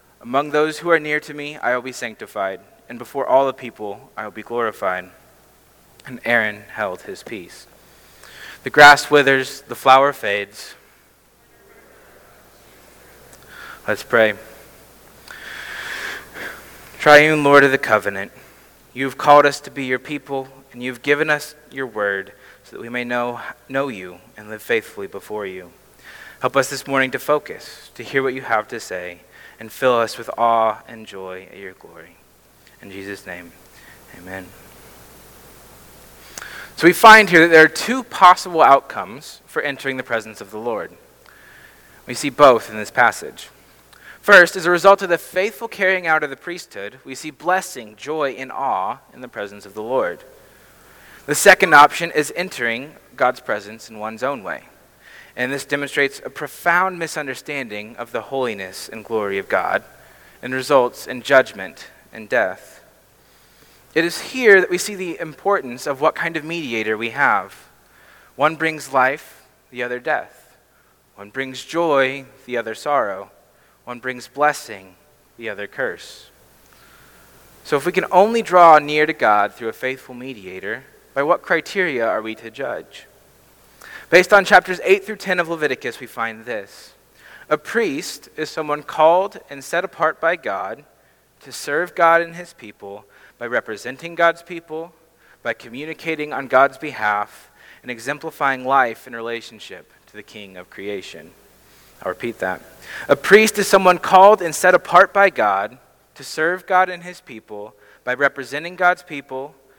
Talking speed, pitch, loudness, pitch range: 160 wpm, 140 Hz, -17 LUFS, 115-165 Hz